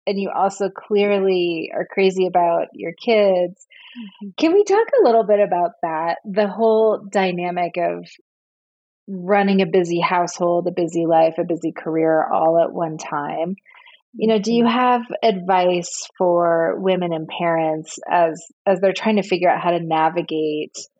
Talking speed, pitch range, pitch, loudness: 155 wpm, 170-205 Hz, 180 Hz, -19 LUFS